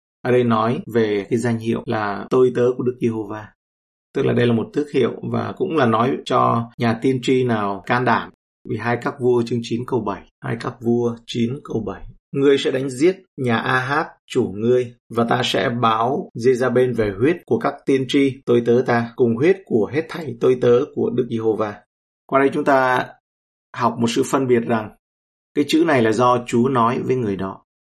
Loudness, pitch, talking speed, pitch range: -19 LUFS, 120 Hz, 215 wpm, 110-130 Hz